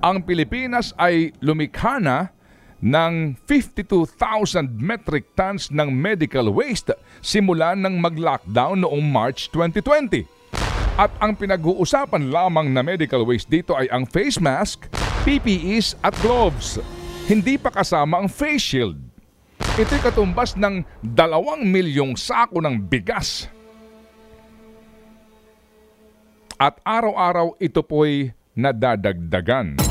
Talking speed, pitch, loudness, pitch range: 105 wpm, 175 Hz, -20 LUFS, 145-220 Hz